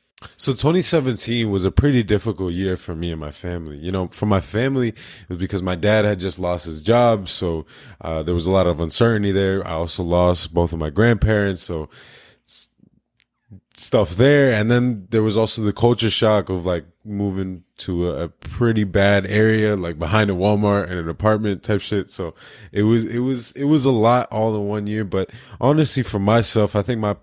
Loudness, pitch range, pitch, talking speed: -19 LUFS, 90-110 Hz, 105 Hz, 205 wpm